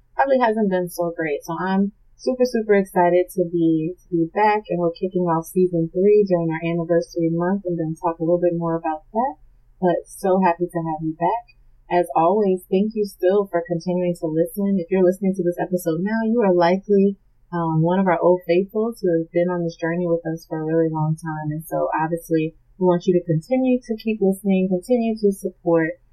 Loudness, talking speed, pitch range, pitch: -21 LUFS, 215 wpm, 165-190 Hz, 175 Hz